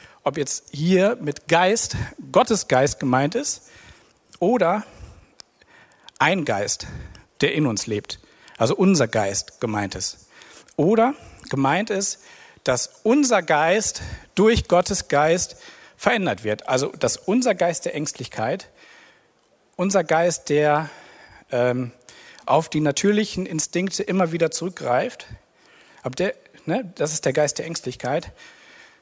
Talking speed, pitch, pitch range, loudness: 120 wpm, 160 Hz, 130-195 Hz, -22 LUFS